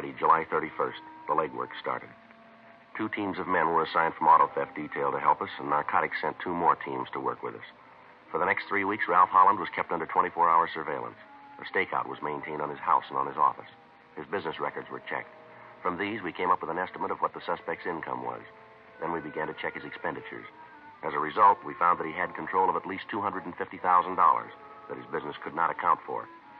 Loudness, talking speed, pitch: -28 LUFS, 220 wpm, 310 Hz